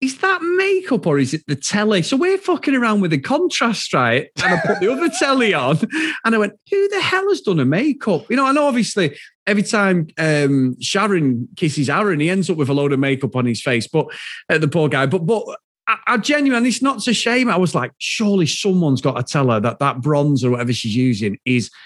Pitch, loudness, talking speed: 190 Hz, -17 LUFS, 240 wpm